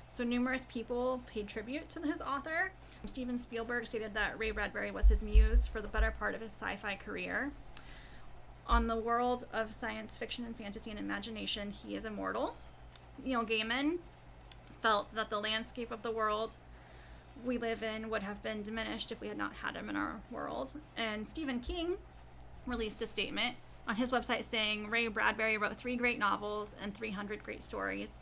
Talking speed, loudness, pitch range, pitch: 180 wpm, -36 LUFS, 210-245 Hz, 225 Hz